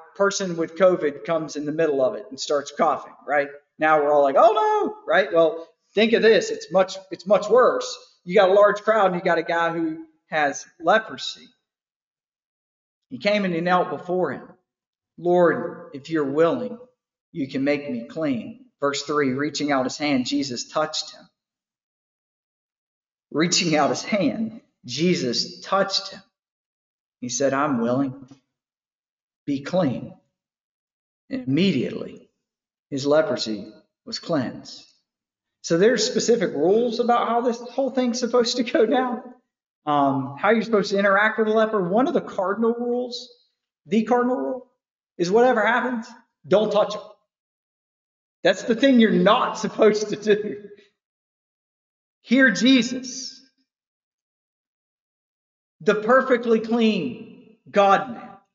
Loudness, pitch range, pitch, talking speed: -21 LUFS, 160-240 Hz, 205 Hz, 140 wpm